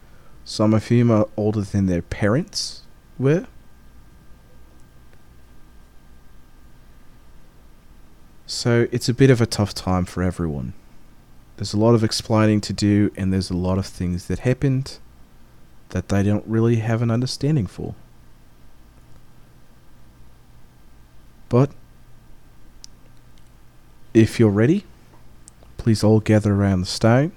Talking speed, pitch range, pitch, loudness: 115 wpm, 70-115 Hz, 105 Hz, -20 LUFS